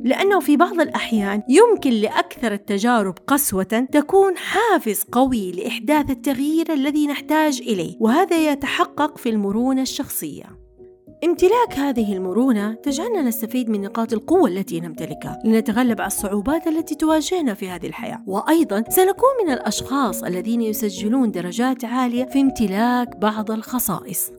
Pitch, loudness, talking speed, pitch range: 250 Hz, -20 LUFS, 125 wpm, 220-305 Hz